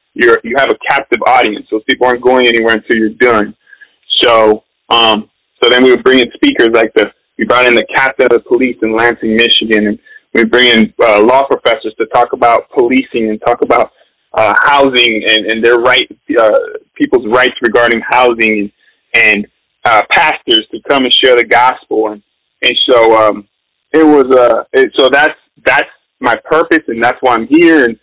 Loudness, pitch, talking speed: -9 LUFS, 125 Hz, 190 wpm